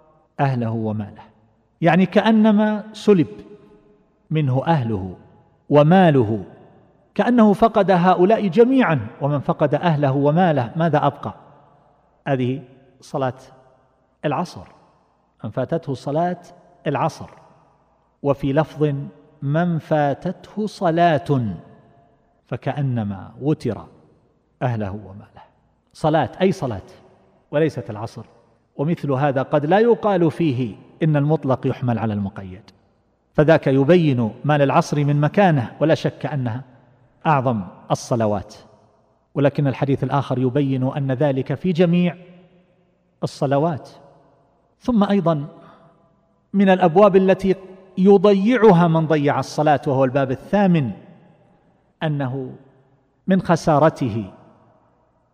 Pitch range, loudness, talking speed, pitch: 130-170 Hz, -19 LUFS, 90 wpm, 145 Hz